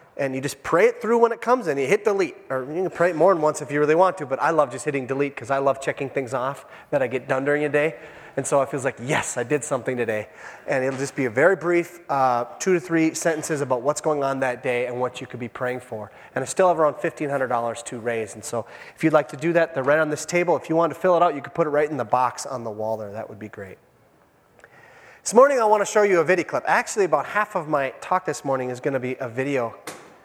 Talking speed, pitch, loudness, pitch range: 295 wpm, 145 Hz, -22 LUFS, 130-170 Hz